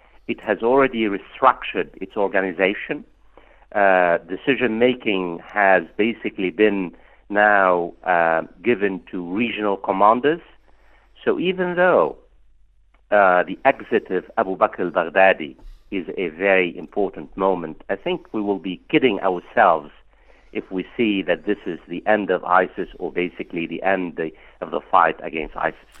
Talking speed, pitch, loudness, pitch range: 145 wpm, 95 Hz, -20 LUFS, 90-110 Hz